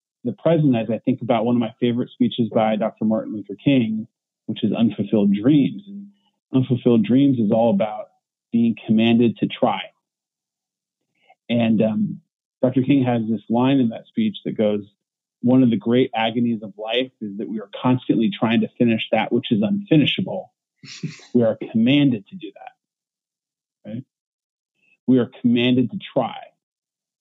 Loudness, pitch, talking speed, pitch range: -20 LUFS, 120 Hz, 160 wpm, 110-140 Hz